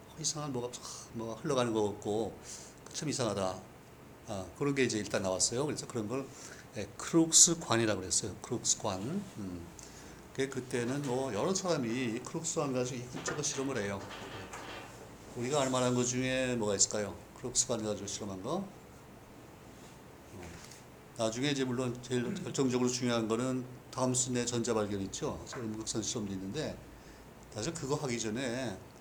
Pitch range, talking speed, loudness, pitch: 105-135 Hz, 320 characters per minute, -33 LUFS, 125 Hz